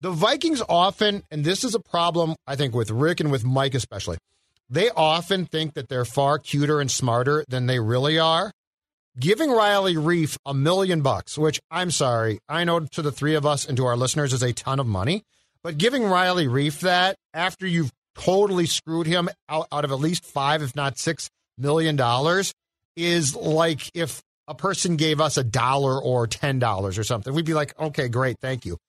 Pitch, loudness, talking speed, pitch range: 155 Hz, -23 LUFS, 195 wpm, 130-170 Hz